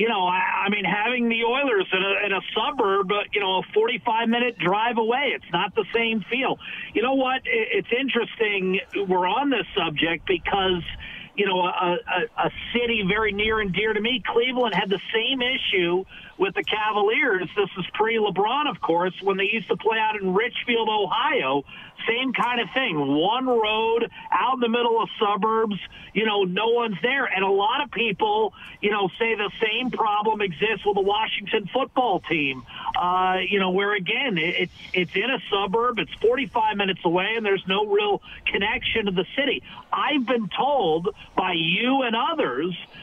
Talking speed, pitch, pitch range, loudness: 185 wpm, 220 Hz, 190-245 Hz, -23 LUFS